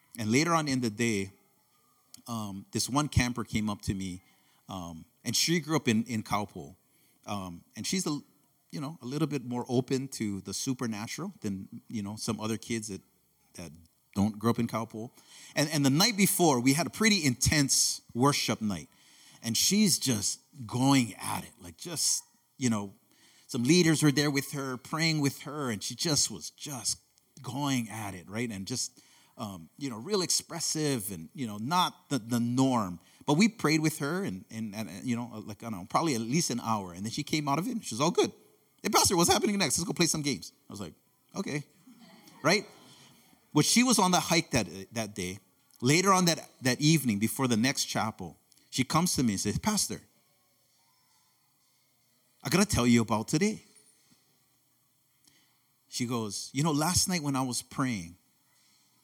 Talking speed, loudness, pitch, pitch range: 195 wpm, -29 LUFS, 130 Hz, 110-150 Hz